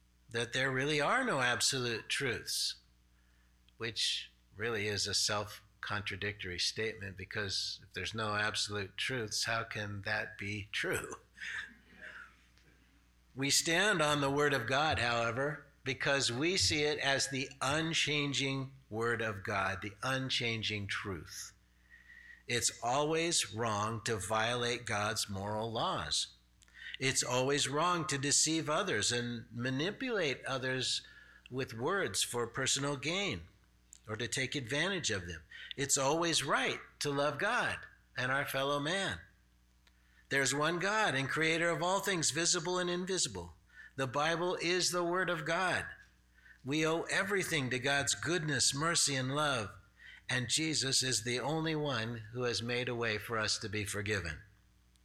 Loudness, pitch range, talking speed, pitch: -33 LUFS, 105-150 Hz, 140 wpm, 125 Hz